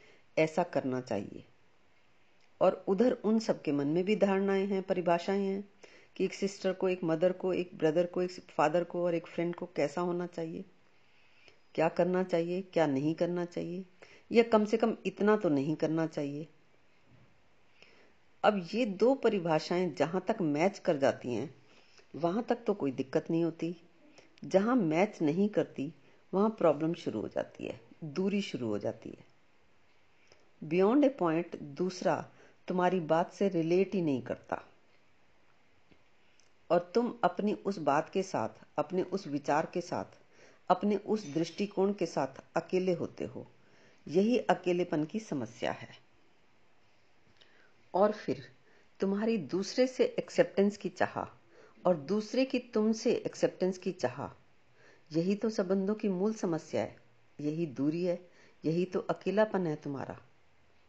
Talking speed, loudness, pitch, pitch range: 145 wpm, -32 LUFS, 180 Hz, 160-195 Hz